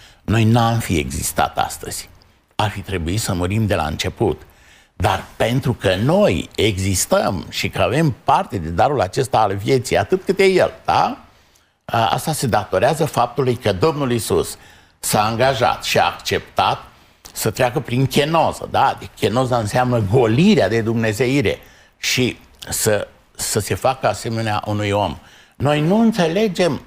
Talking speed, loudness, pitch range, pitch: 145 wpm, -18 LUFS, 105-140 Hz, 115 Hz